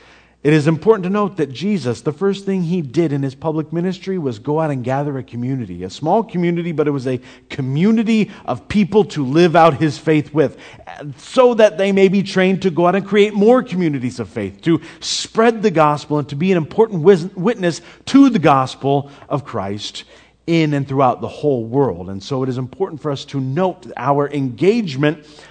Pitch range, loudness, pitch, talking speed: 140-190 Hz, -17 LUFS, 160 Hz, 200 wpm